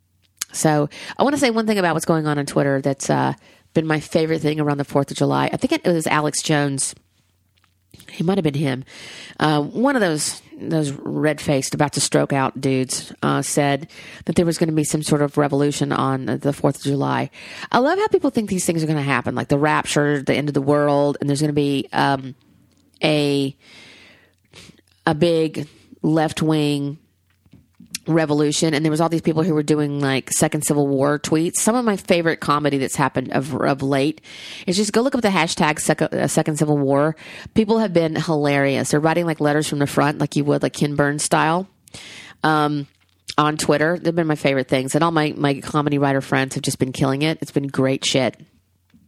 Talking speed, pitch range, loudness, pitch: 205 wpm, 140-160 Hz, -20 LUFS, 150 Hz